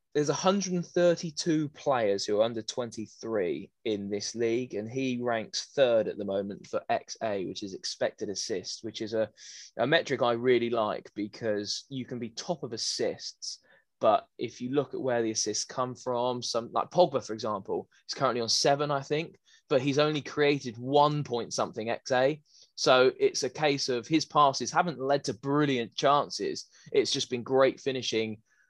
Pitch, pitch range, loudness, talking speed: 130 Hz, 115-150 Hz, -29 LUFS, 175 wpm